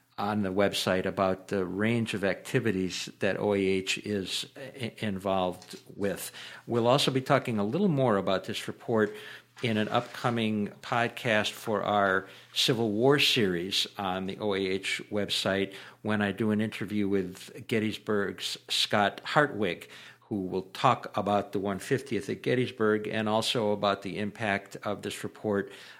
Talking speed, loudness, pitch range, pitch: 140 wpm, -29 LUFS, 95-115 Hz, 105 Hz